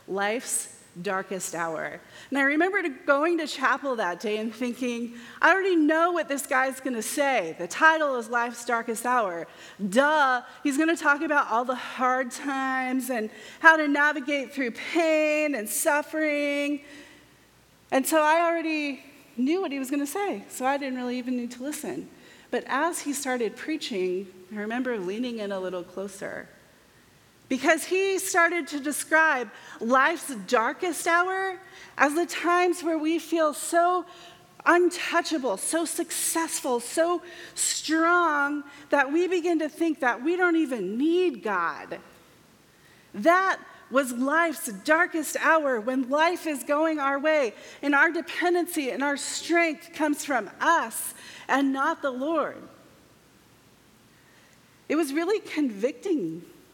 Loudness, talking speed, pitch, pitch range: -25 LUFS, 145 wpm, 290 Hz, 255-330 Hz